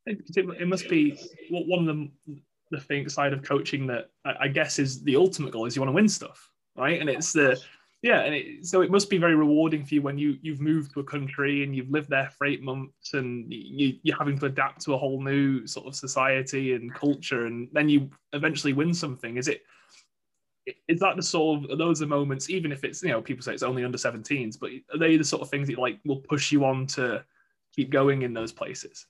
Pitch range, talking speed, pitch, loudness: 135-160 Hz, 240 wpm, 145 Hz, -26 LUFS